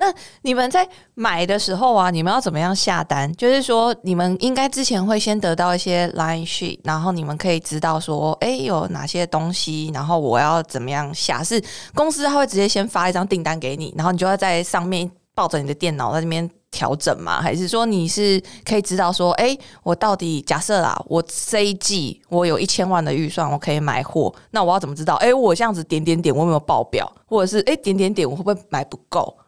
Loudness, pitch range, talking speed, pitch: -20 LUFS, 160-205 Hz, 340 characters per minute, 175 Hz